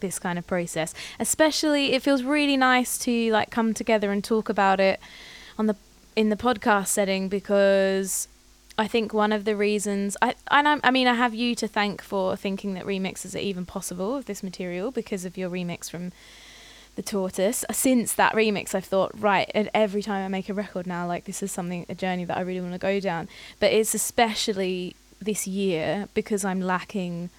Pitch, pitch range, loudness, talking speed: 200 Hz, 190-220 Hz, -25 LUFS, 205 wpm